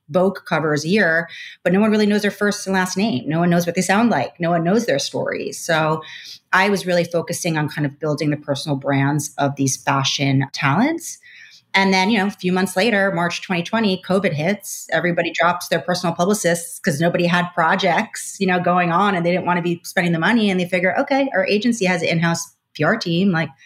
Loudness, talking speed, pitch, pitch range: -19 LUFS, 225 wpm, 175 Hz, 165-195 Hz